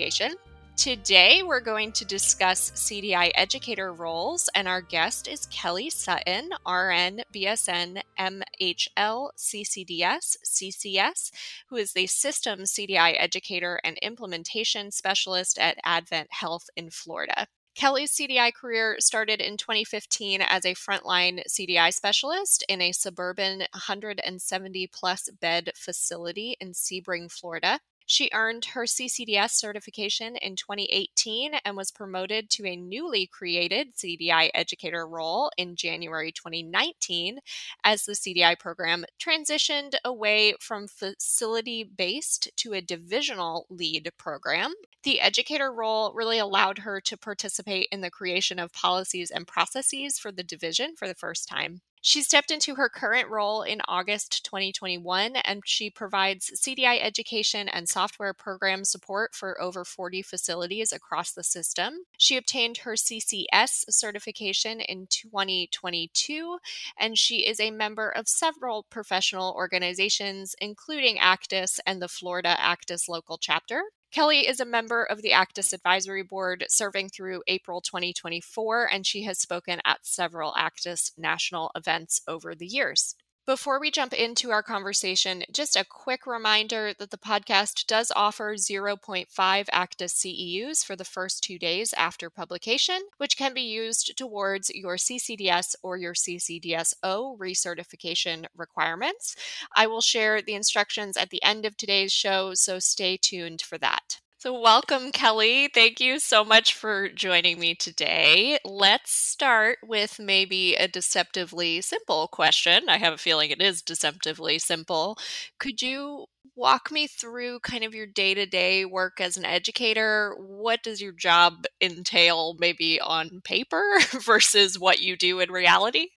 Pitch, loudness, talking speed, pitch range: 195 Hz, -24 LUFS, 140 wpm, 180-225 Hz